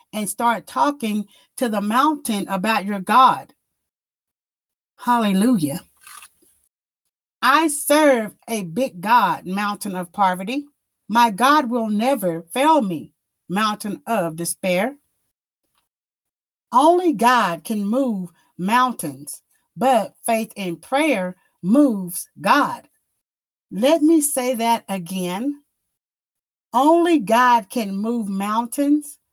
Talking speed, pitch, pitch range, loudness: 100 wpm, 230 Hz, 195-270 Hz, -19 LUFS